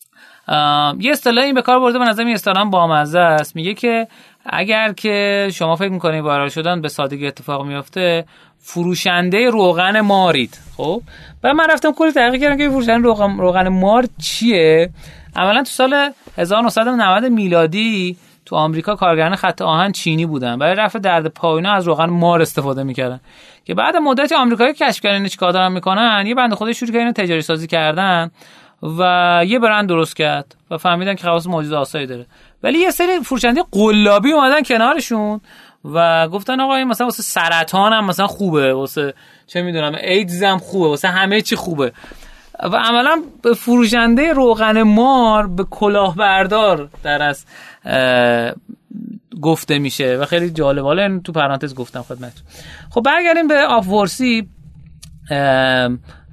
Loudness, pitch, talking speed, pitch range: -15 LUFS, 185 Hz, 150 wpm, 160-230 Hz